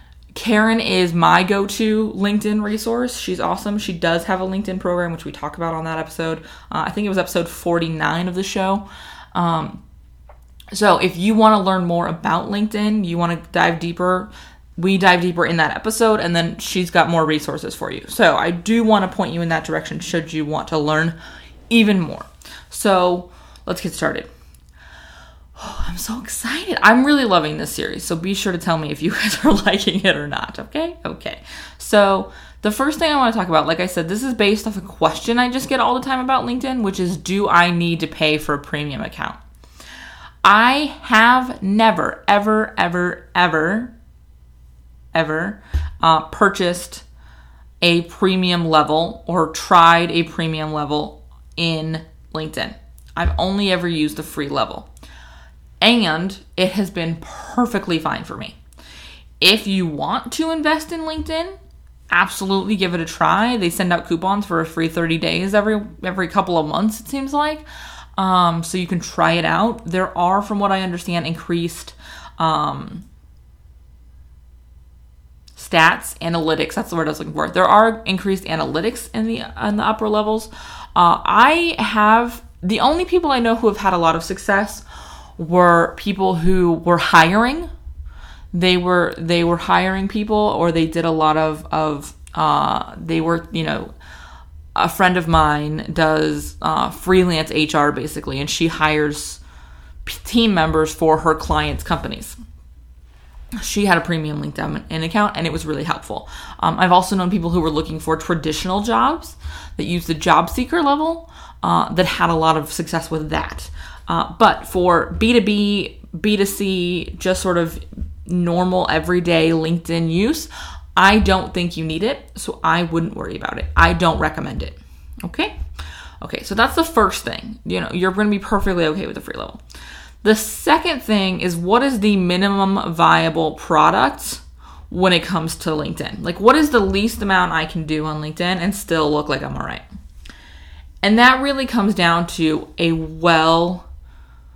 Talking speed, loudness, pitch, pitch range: 175 wpm, -18 LUFS, 175 Hz, 155-205 Hz